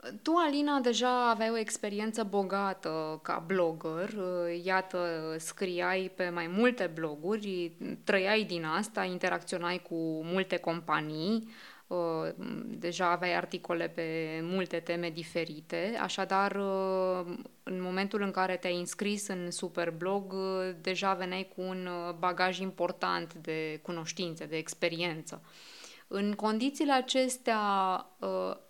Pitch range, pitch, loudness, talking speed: 170-200 Hz, 185 Hz, -33 LUFS, 105 wpm